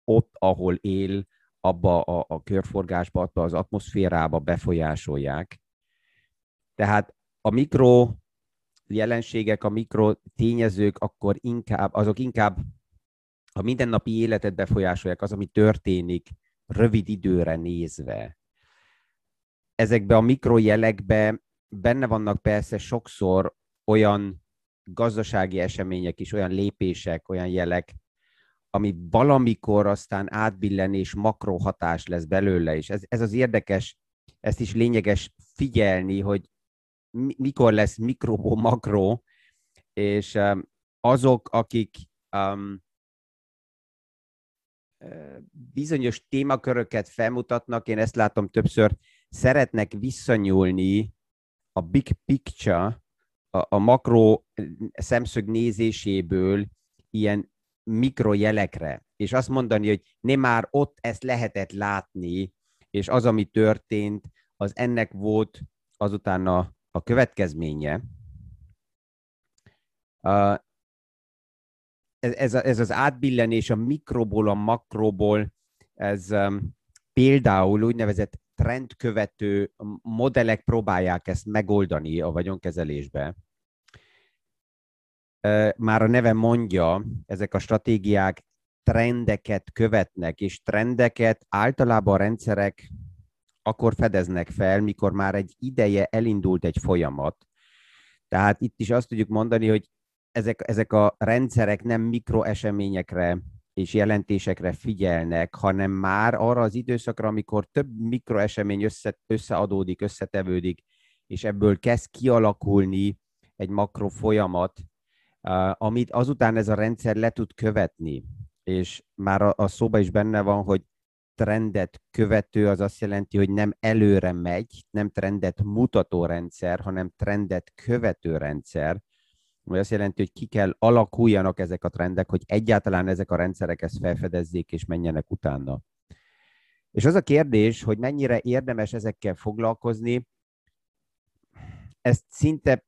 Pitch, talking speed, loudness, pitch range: 105 Hz, 110 wpm, -24 LUFS, 95-115 Hz